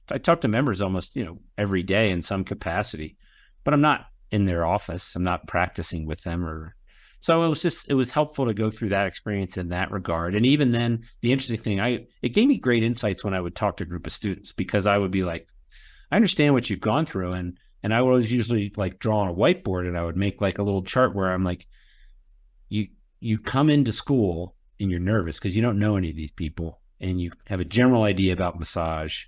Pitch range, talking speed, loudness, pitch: 90-115 Hz, 240 wpm, -24 LUFS, 100 Hz